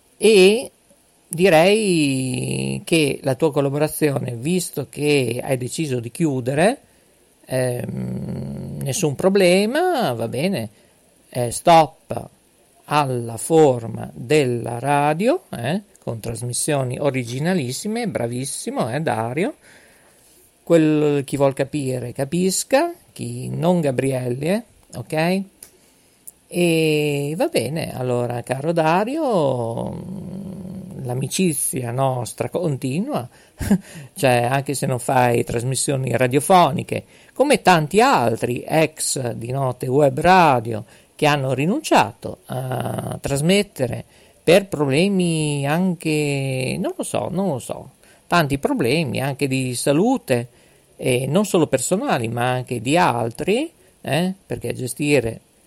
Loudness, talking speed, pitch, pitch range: -20 LUFS, 100 wpm, 145 Hz, 125-175 Hz